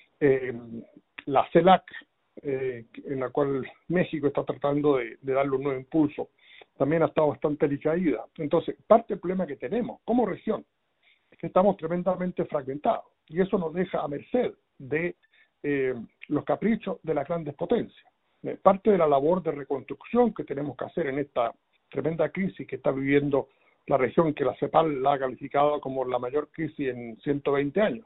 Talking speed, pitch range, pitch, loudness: 175 wpm, 140-175 Hz, 150 Hz, -27 LUFS